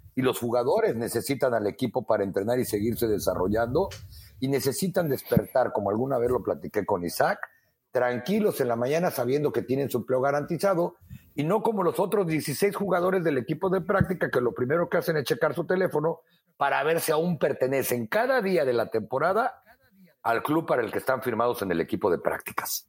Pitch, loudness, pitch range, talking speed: 145 Hz, -26 LUFS, 120-175 Hz, 190 wpm